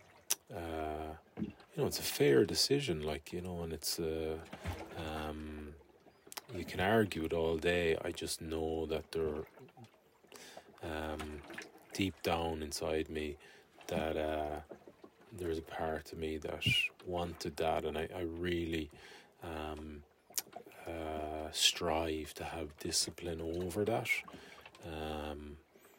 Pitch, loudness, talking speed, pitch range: 80 Hz, -37 LUFS, 125 wpm, 75-85 Hz